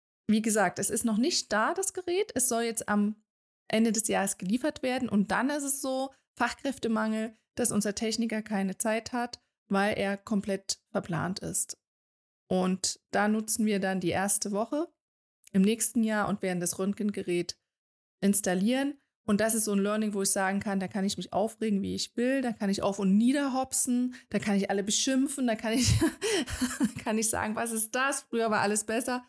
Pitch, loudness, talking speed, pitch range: 220 Hz, -29 LUFS, 195 wpm, 200-245 Hz